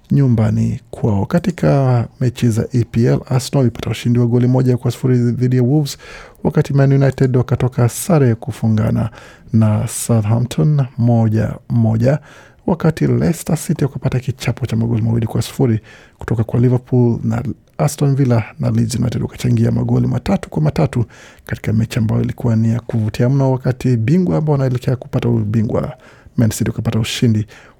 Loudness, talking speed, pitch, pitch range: -16 LUFS, 135 wpm, 120 Hz, 115-135 Hz